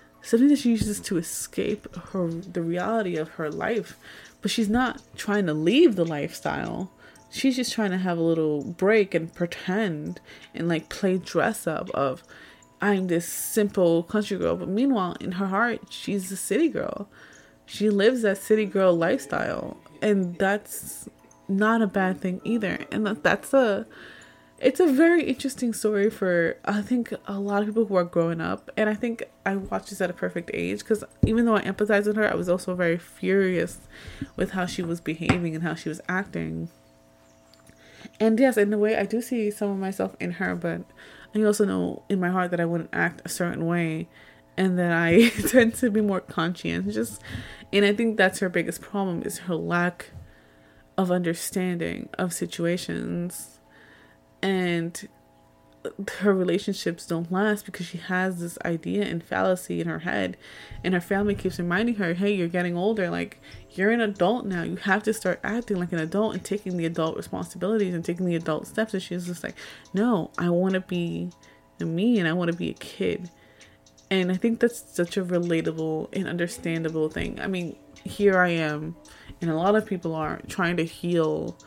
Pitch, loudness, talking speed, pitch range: 185 Hz, -25 LUFS, 185 wpm, 170-210 Hz